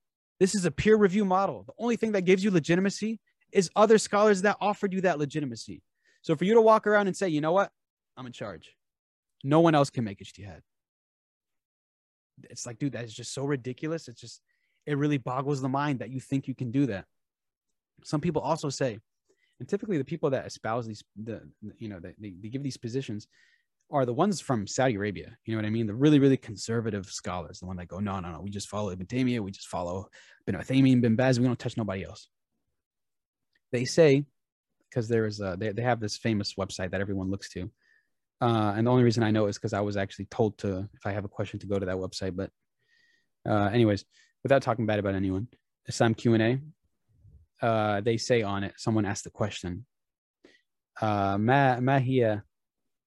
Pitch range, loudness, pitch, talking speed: 100-145 Hz, -27 LUFS, 120 Hz, 210 wpm